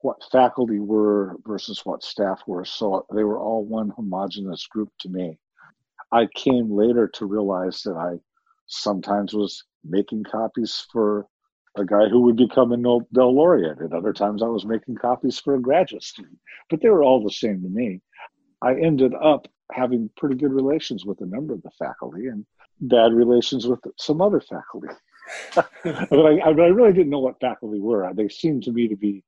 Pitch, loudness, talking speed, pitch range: 115 Hz, -21 LUFS, 185 wpm, 105-125 Hz